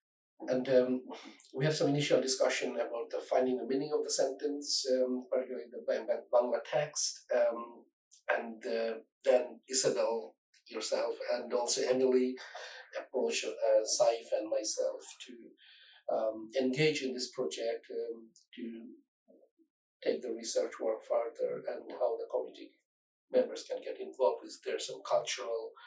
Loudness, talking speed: -33 LUFS, 135 wpm